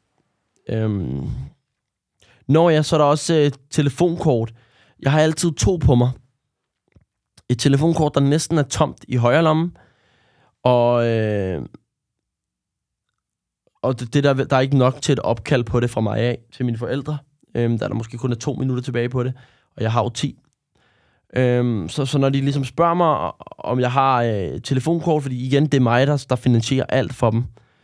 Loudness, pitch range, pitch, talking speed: -20 LUFS, 120-145 Hz, 130 Hz, 180 wpm